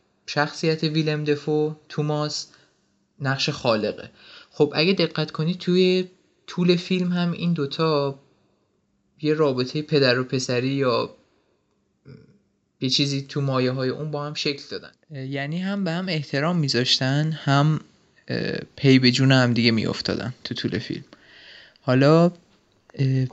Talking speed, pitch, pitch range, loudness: 125 wpm, 150 Hz, 135-160 Hz, -22 LUFS